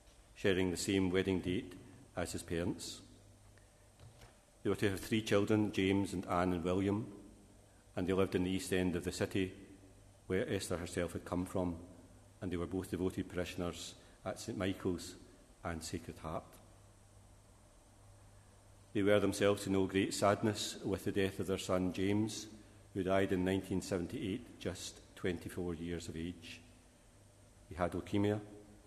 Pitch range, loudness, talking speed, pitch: 90-100 Hz, -37 LUFS, 150 wpm, 95 Hz